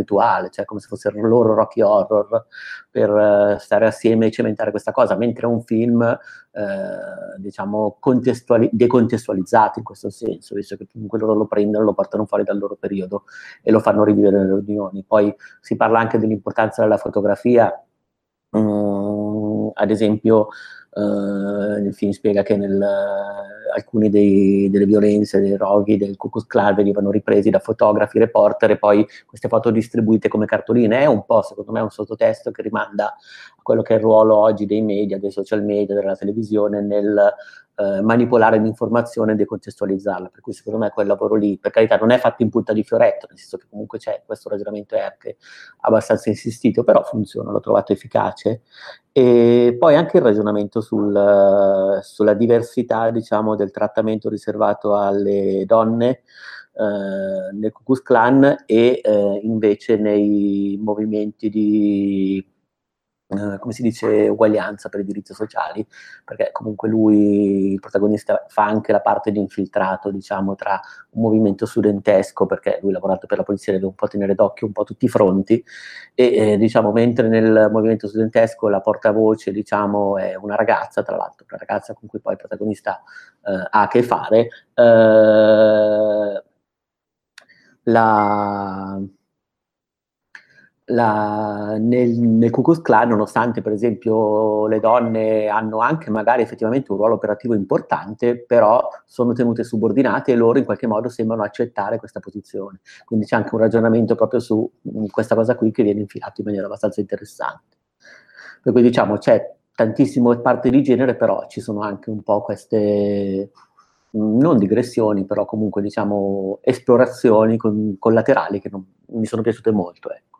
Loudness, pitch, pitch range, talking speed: -18 LUFS, 105 Hz, 100-115 Hz, 160 wpm